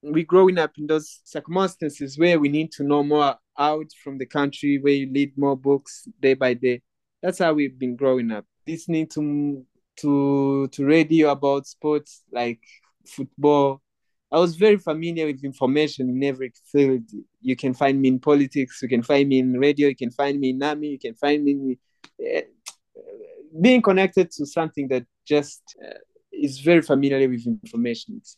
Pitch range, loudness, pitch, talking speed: 135-160 Hz, -22 LUFS, 145 Hz, 180 wpm